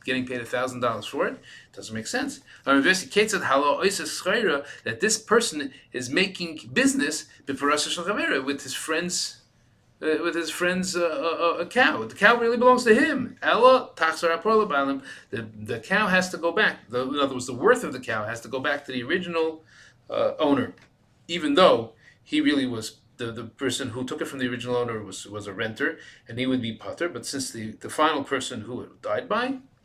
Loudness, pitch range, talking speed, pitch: -24 LUFS, 125-195 Hz, 180 wpm, 155 Hz